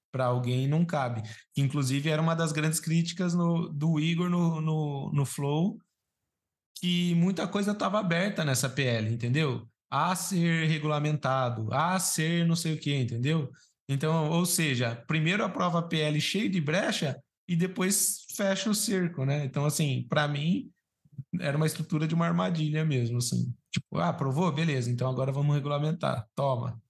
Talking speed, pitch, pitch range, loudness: 165 wpm, 155 Hz, 135-170 Hz, -28 LUFS